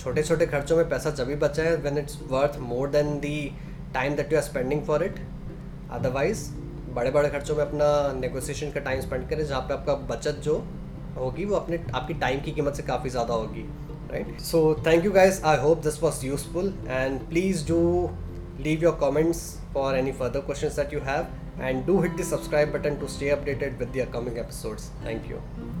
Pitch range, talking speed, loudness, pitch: 135-155 Hz, 200 wpm, -26 LUFS, 145 Hz